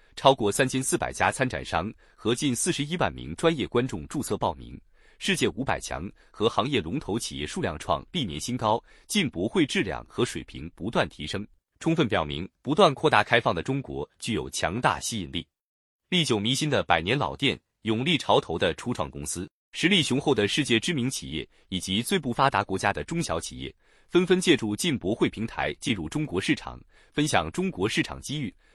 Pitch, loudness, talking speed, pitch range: 120 Hz, -26 LUFS, 295 characters per minute, 100-150 Hz